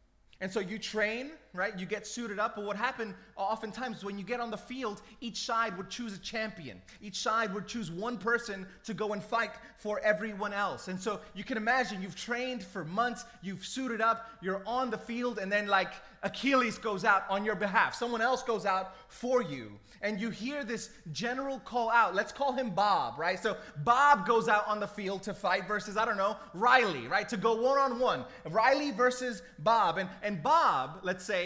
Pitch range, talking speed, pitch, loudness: 195-235 Hz, 205 wpm, 215 Hz, -31 LUFS